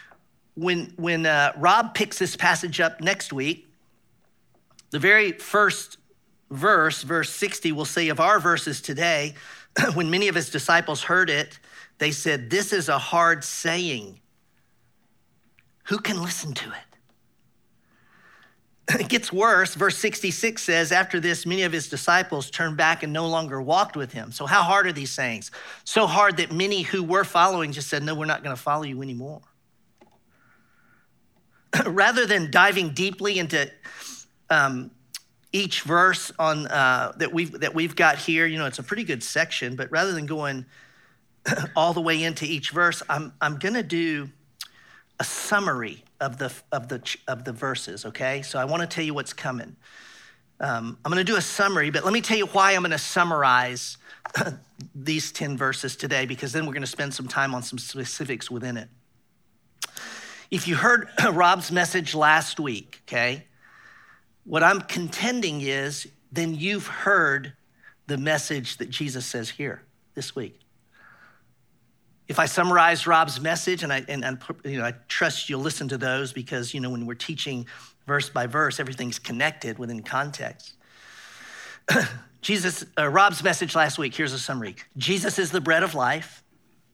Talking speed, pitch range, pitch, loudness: 165 wpm, 135-175 Hz, 155 Hz, -23 LUFS